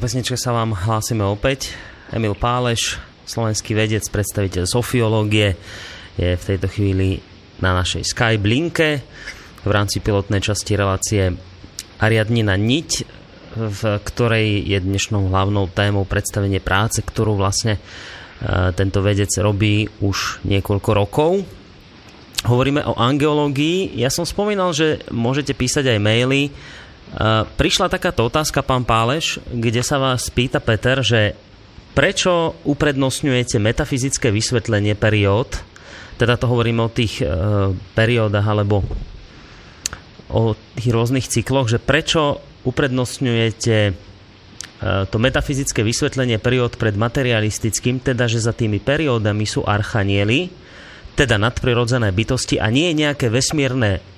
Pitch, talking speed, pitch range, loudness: 110 Hz, 115 wpm, 100-130 Hz, -18 LUFS